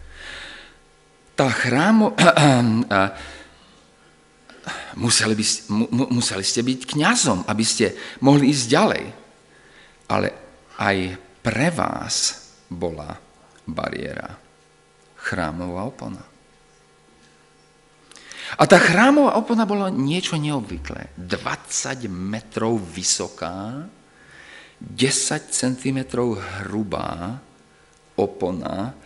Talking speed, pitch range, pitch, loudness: 75 wpm, 95-135 Hz, 115 Hz, -20 LUFS